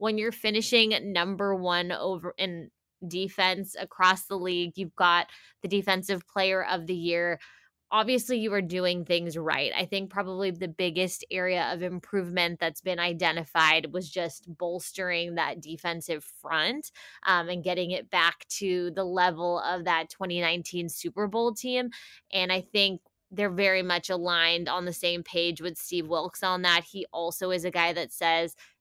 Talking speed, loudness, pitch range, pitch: 165 wpm, -28 LUFS, 170-190 Hz, 180 Hz